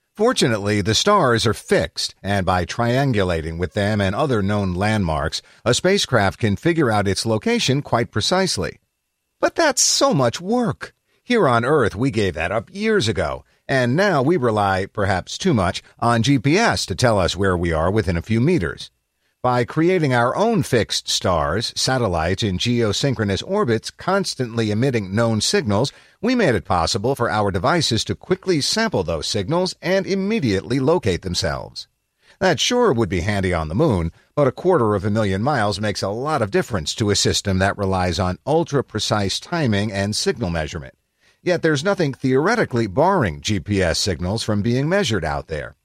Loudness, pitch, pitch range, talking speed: -19 LUFS, 110 Hz, 95-140 Hz, 170 wpm